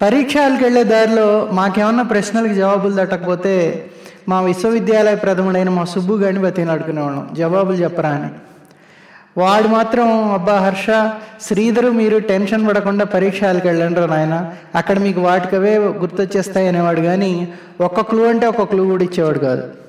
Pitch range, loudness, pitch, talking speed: 180-215 Hz, -15 LUFS, 195 Hz, 125 wpm